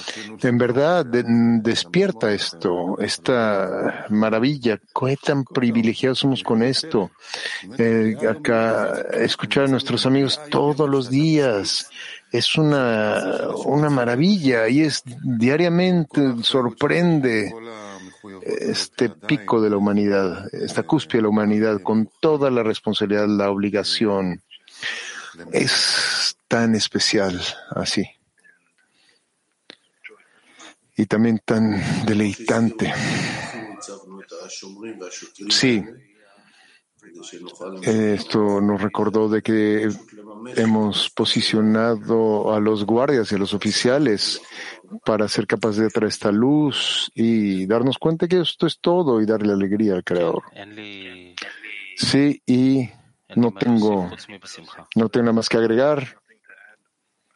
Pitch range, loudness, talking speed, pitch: 105-130 Hz, -20 LUFS, 105 wpm, 115 Hz